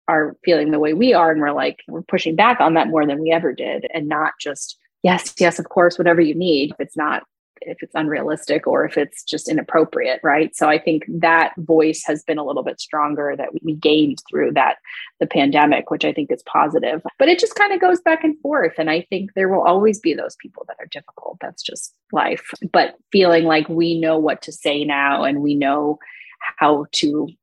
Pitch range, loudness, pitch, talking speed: 150-195 Hz, -18 LUFS, 165 Hz, 225 wpm